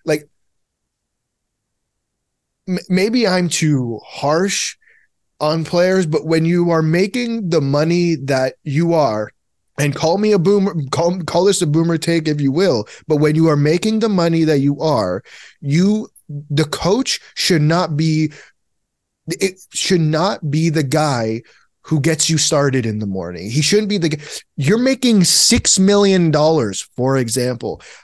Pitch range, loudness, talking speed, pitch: 150-180 Hz, -16 LUFS, 150 wpm, 160 Hz